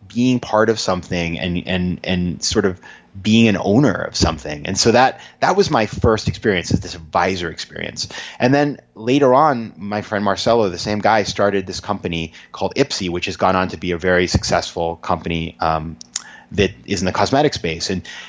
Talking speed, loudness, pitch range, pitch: 195 wpm, -18 LUFS, 85-105 Hz, 95 Hz